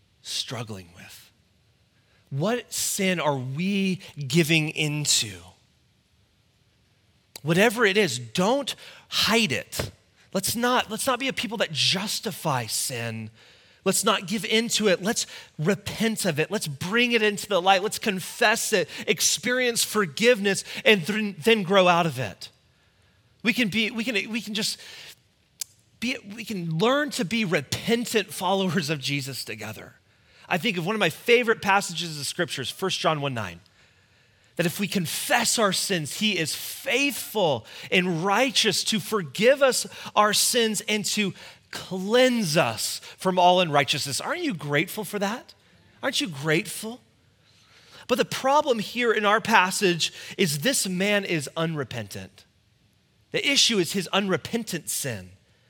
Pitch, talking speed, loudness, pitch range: 185 Hz, 145 wpm, -24 LUFS, 140-220 Hz